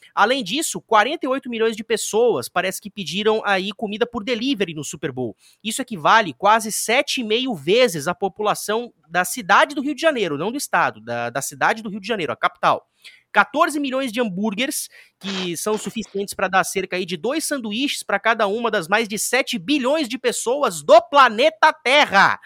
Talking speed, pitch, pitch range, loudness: 185 wpm, 220 Hz, 195-265 Hz, -20 LUFS